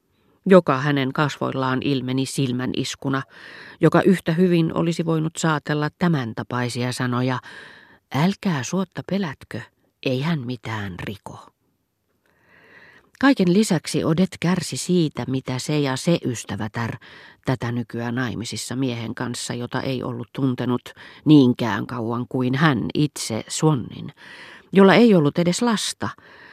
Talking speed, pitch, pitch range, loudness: 120 wpm, 135 Hz, 125-165 Hz, -21 LUFS